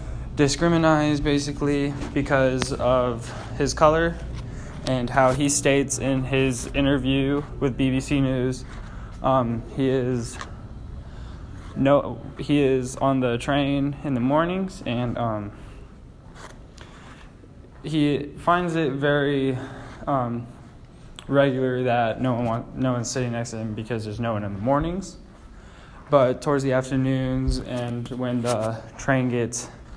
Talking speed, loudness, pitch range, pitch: 125 wpm, -23 LUFS, 120-140 Hz, 130 Hz